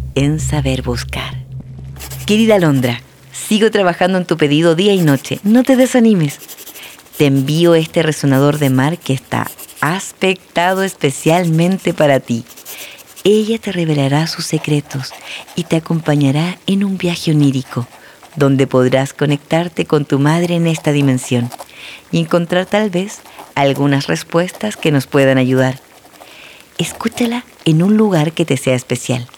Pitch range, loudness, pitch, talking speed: 135-180 Hz, -14 LUFS, 155 Hz, 135 wpm